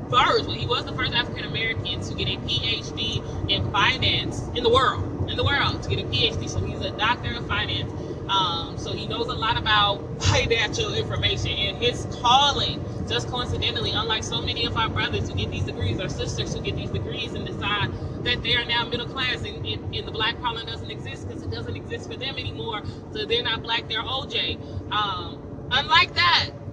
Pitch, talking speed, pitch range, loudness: 115 Hz, 205 wpm, 105-120 Hz, -24 LUFS